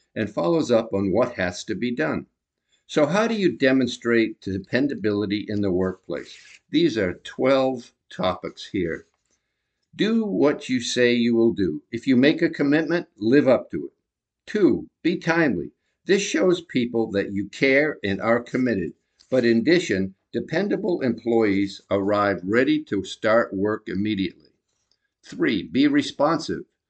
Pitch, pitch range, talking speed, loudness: 120 Hz, 105-165 Hz, 145 wpm, -22 LUFS